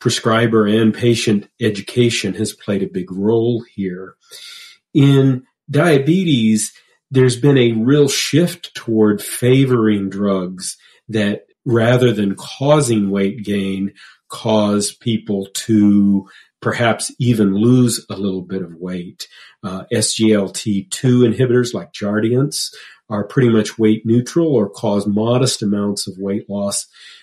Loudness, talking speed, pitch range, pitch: -16 LUFS, 120 wpm, 100-125 Hz, 110 Hz